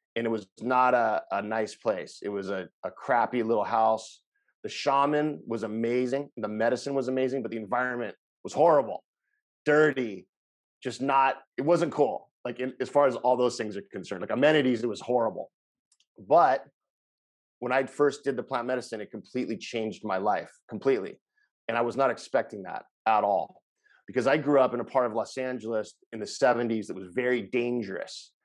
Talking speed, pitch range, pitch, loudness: 185 wpm, 115-140 Hz, 125 Hz, -28 LUFS